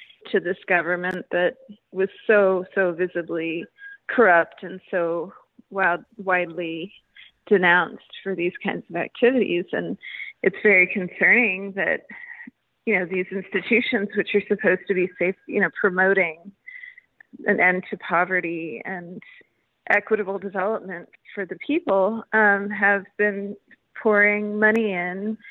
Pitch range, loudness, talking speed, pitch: 180-215 Hz, -22 LUFS, 125 wpm, 195 Hz